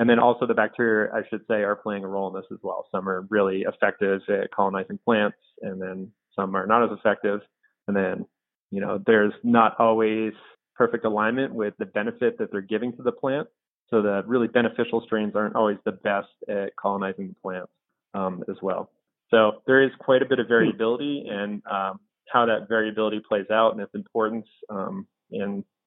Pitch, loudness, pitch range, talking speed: 110 Hz, -24 LUFS, 100-115 Hz, 195 wpm